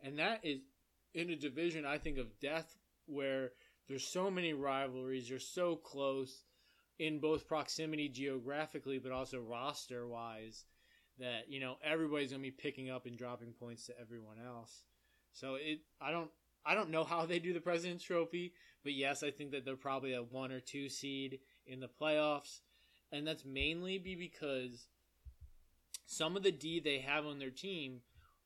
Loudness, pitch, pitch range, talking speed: -41 LUFS, 140 Hz, 130-155 Hz, 170 wpm